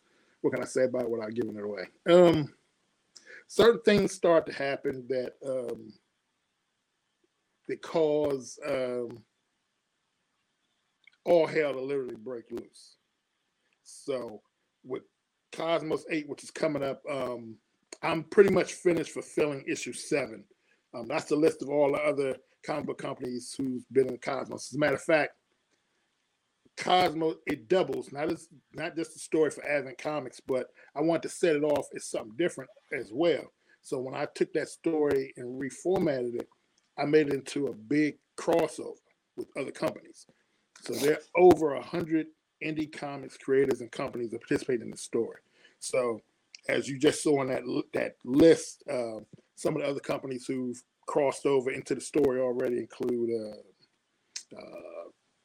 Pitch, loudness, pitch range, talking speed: 145 Hz, -29 LUFS, 130-165 Hz, 160 wpm